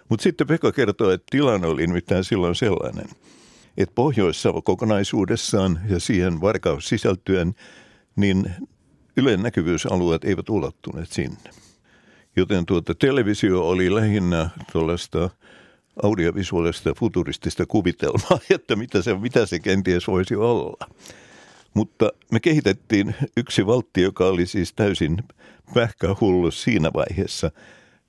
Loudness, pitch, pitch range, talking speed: -22 LUFS, 95 Hz, 90-100 Hz, 110 wpm